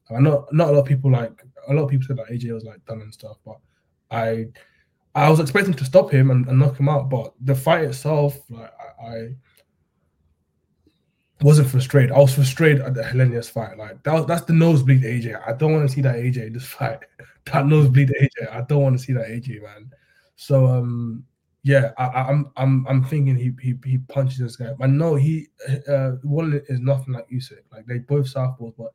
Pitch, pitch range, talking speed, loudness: 130 Hz, 120-140 Hz, 220 wpm, -19 LUFS